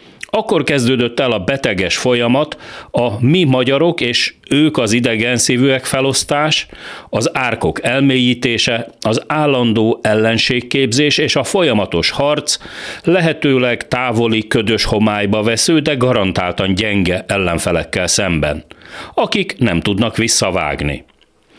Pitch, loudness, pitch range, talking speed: 120 Hz, -14 LUFS, 110-135 Hz, 110 wpm